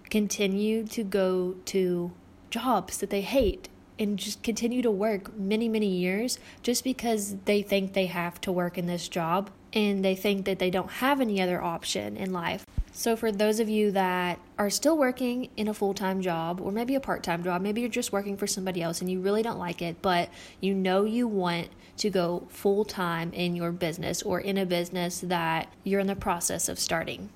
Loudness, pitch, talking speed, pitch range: -28 LUFS, 195 Hz, 210 wpm, 180-215 Hz